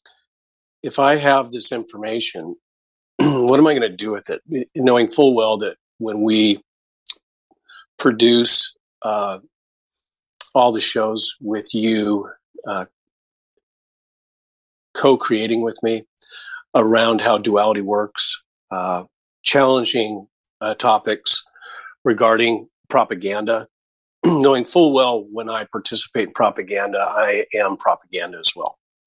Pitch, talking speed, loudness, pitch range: 115 Hz, 110 wpm, -18 LUFS, 110-135 Hz